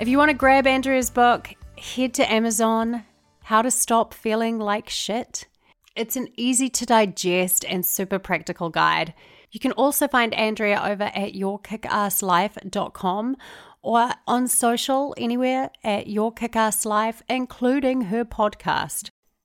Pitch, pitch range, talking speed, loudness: 225 Hz, 205-250 Hz, 135 wpm, -22 LUFS